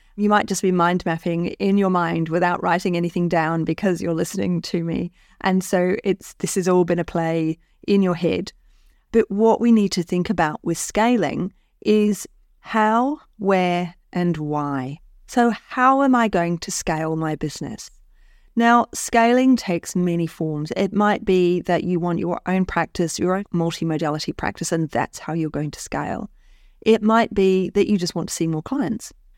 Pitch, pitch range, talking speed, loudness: 180 Hz, 165-200 Hz, 185 wpm, -21 LUFS